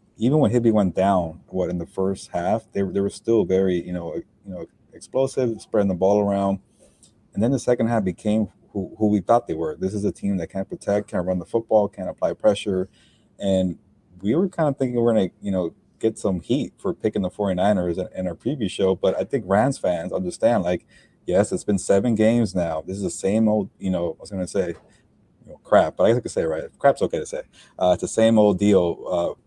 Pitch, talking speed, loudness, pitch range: 100 Hz, 245 wpm, -22 LUFS, 95-115 Hz